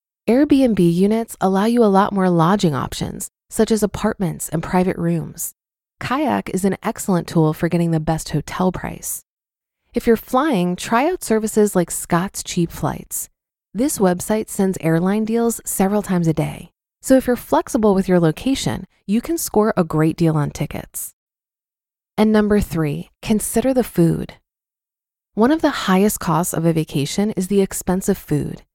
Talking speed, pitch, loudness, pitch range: 165 wpm, 195 Hz, -19 LUFS, 170-220 Hz